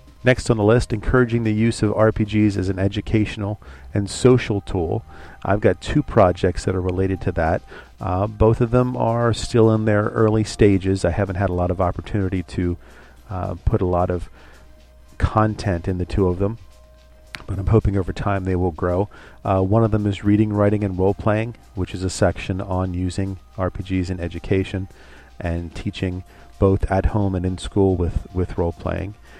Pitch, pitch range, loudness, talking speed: 95 Hz, 90-105 Hz, -21 LUFS, 190 wpm